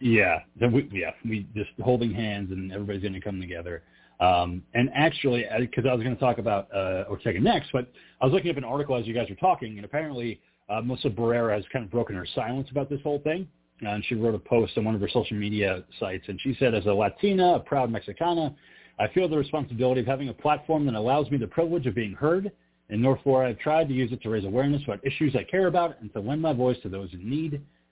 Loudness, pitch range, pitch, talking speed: -27 LUFS, 105-140 Hz, 120 Hz, 255 wpm